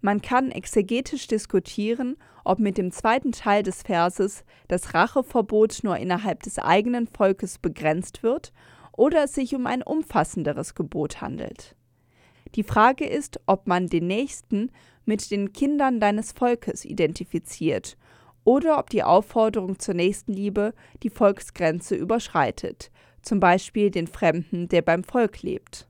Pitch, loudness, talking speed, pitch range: 205 Hz, -24 LUFS, 135 wpm, 180-235 Hz